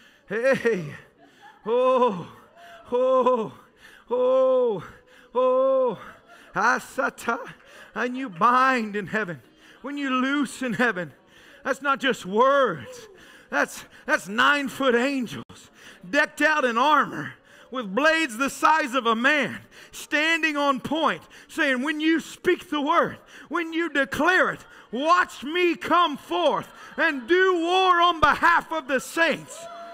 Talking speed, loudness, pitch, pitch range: 120 wpm, -23 LUFS, 295 Hz, 260-345 Hz